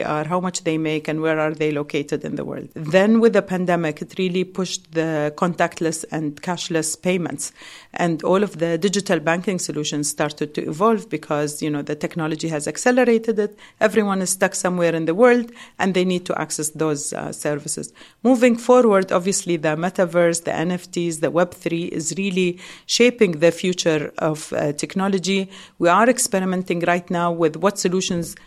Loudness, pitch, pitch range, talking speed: -20 LUFS, 175 Hz, 155-190 Hz, 175 wpm